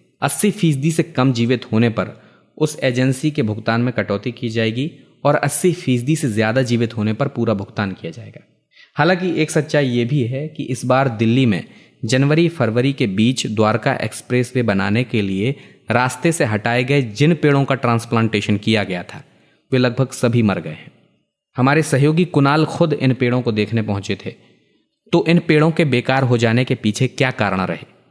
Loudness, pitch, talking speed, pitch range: -18 LUFS, 130 Hz, 185 wpm, 115-145 Hz